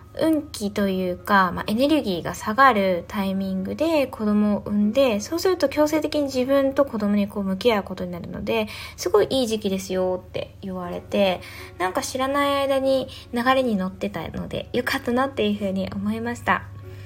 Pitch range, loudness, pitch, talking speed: 190-270 Hz, -23 LUFS, 215 Hz, 380 characters per minute